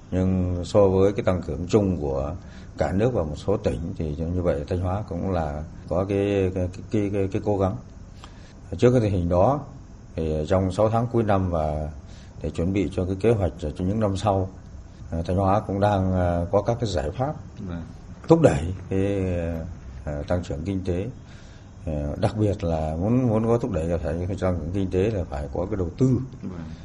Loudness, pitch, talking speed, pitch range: -24 LUFS, 95 Hz, 200 wpm, 85-100 Hz